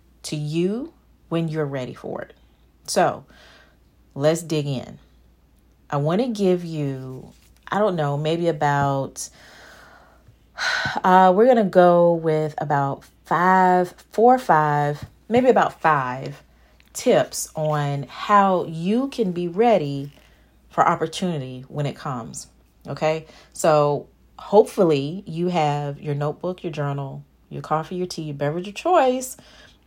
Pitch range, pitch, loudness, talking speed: 145-185 Hz, 155 Hz, -21 LUFS, 125 wpm